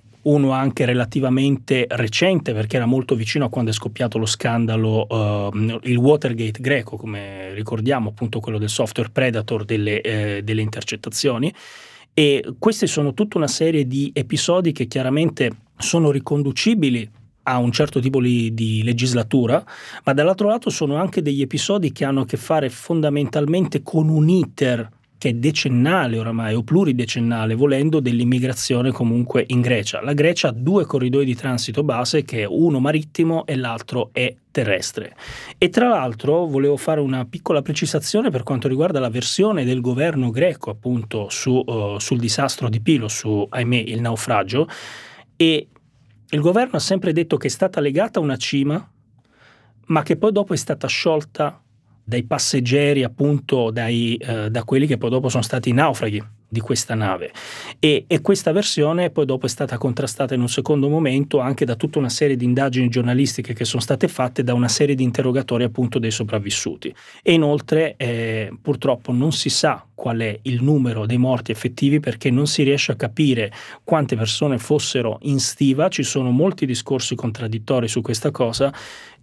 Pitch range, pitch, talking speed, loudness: 120-150 Hz, 130 Hz, 165 wpm, -20 LUFS